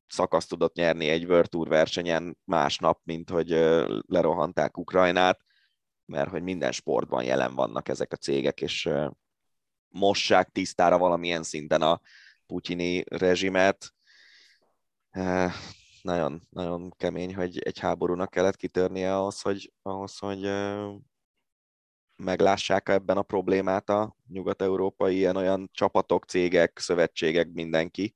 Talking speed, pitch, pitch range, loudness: 110 wpm, 90 Hz, 85-95 Hz, -26 LUFS